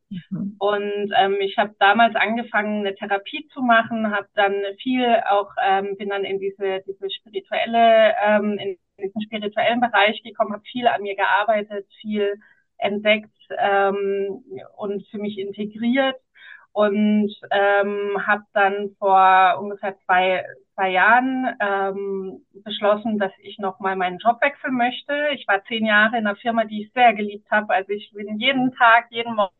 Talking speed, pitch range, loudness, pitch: 155 wpm, 200-230 Hz, -20 LUFS, 205 Hz